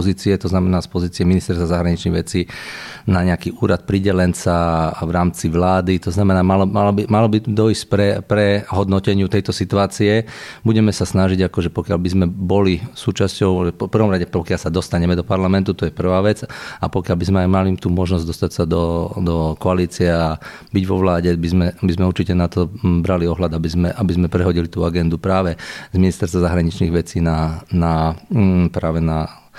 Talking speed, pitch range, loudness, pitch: 185 wpm, 85-100 Hz, -18 LUFS, 90 Hz